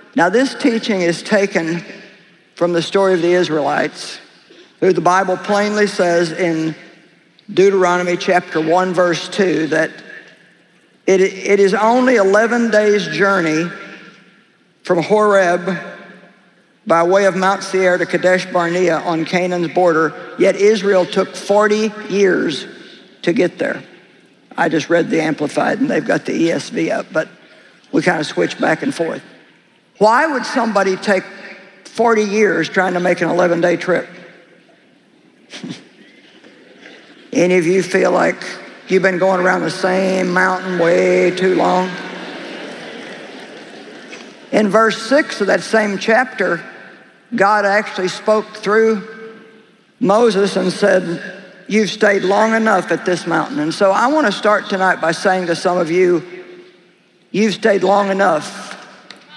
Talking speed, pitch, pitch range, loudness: 135 wpm, 190 Hz, 175-210 Hz, -15 LUFS